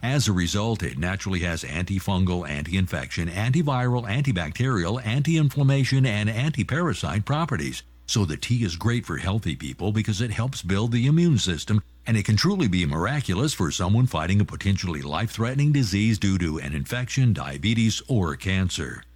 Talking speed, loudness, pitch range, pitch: 165 wpm, -24 LUFS, 90-125 Hz, 105 Hz